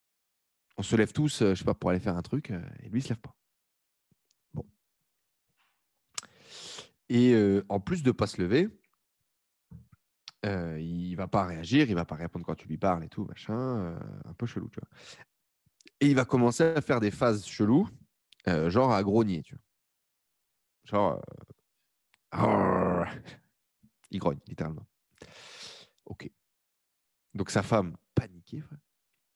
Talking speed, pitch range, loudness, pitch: 160 wpm, 85-120 Hz, -29 LUFS, 100 Hz